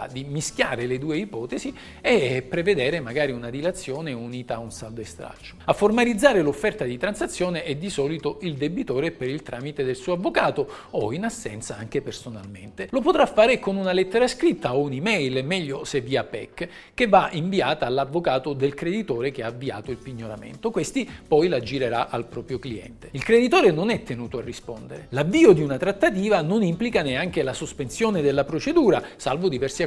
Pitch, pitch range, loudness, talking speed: 150 Hz, 130-205 Hz, -23 LUFS, 175 wpm